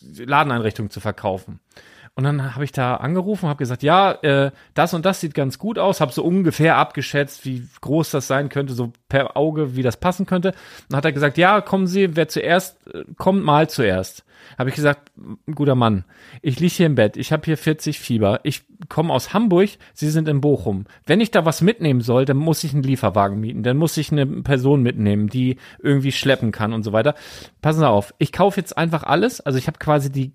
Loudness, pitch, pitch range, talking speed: -19 LUFS, 145 Hz, 130-160 Hz, 215 wpm